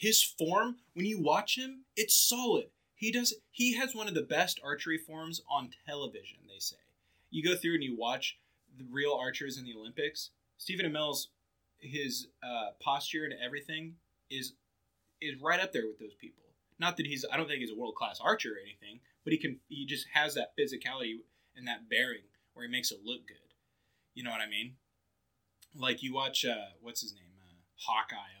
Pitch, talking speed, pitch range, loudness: 145 Hz, 195 wpm, 115-190 Hz, -34 LUFS